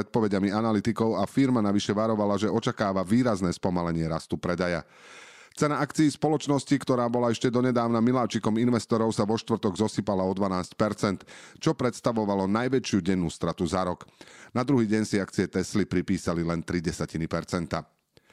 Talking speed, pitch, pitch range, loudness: 145 wpm, 110 Hz, 95-120 Hz, -27 LUFS